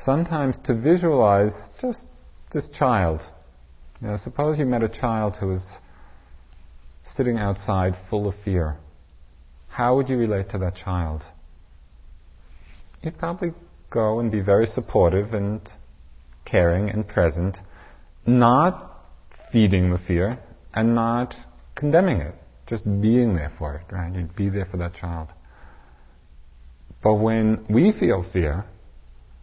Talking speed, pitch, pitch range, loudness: 130 wpm, 95 Hz, 75-115 Hz, -22 LUFS